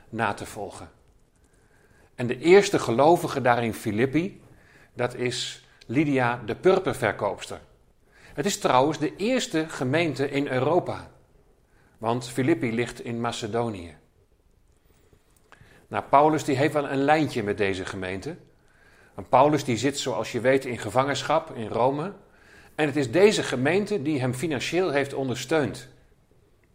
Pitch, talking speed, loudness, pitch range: 130 Hz, 130 wpm, -24 LUFS, 115-155 Hz